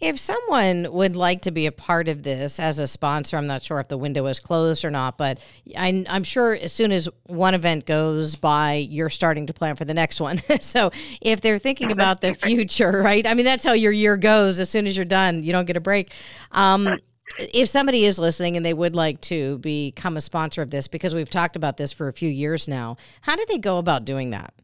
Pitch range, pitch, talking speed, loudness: 150-195 Hz, 170 Hz, 240 wpm, -21 LUFS